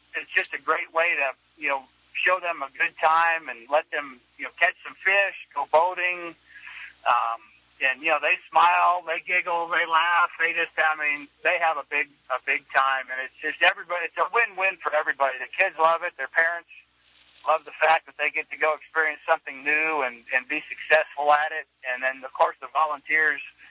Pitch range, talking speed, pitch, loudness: 140-170 Hz, 210 wpm, 155 Hz, -24 LUFS